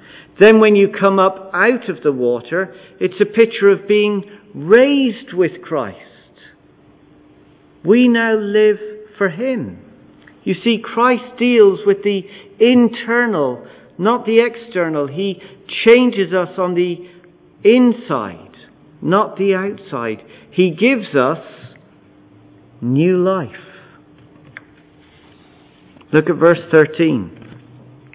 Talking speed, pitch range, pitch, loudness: 105 wpm, 175-230 Hz, 200 Hz, -15 LUFS